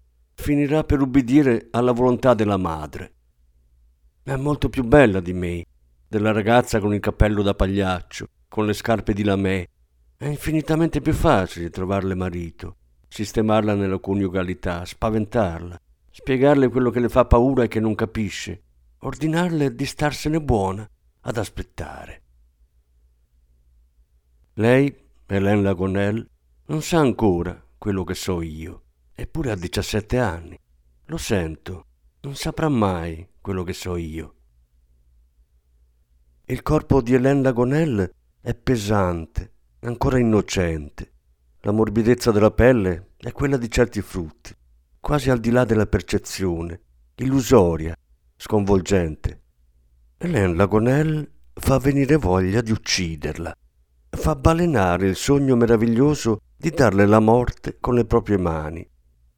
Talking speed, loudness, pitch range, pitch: 120 wpm, -21 LUFS, 75-120 Hz, 100 Hz